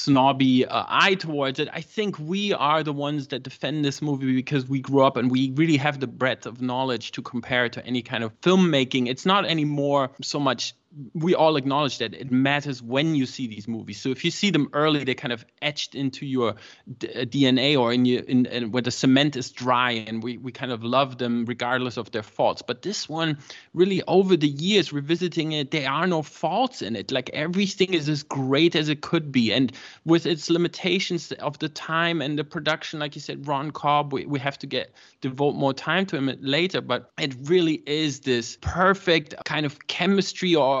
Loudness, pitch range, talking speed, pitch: -24 LUFS, 130-160 Hz, 215 wpm, 140 Hz